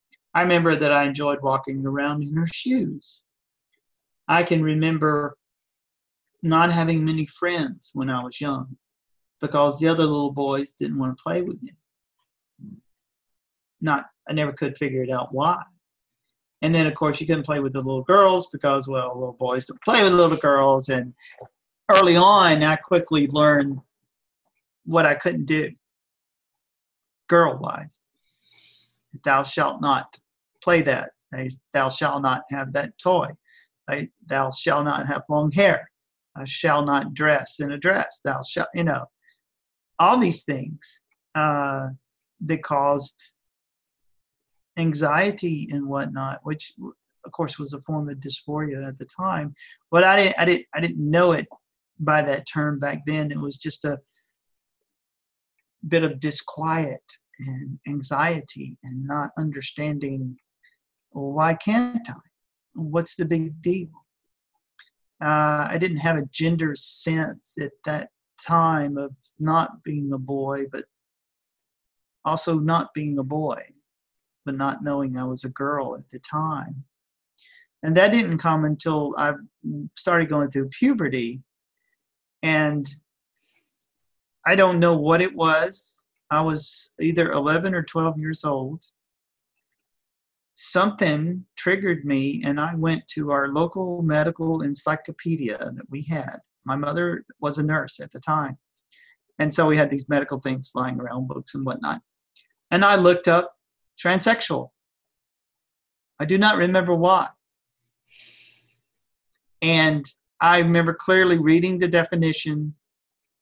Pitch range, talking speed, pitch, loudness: 140-170 Hz, 140 wpm, 150 Hz, -22 LUFS